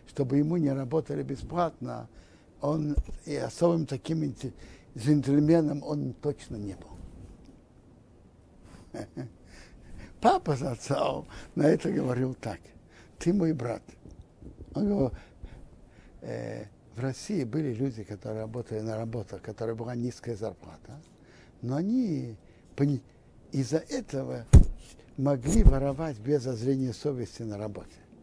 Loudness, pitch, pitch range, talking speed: -29 LUFS, 125 Hz, 110-145 Hz, 110 wpm